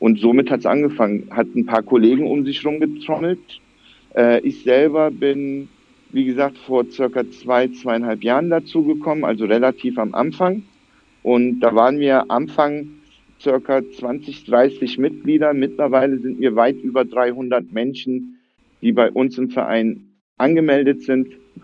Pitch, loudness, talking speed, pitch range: 130 Hz, -18 LUFS, 145 wpm, 125-145 Hz